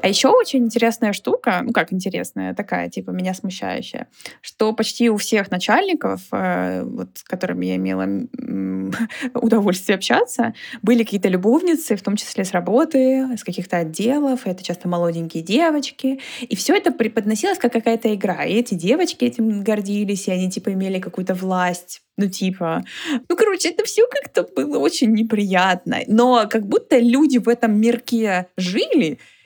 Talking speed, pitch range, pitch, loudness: 155 wpm, 185-245 Hz, 220 Hz, -19 LUFS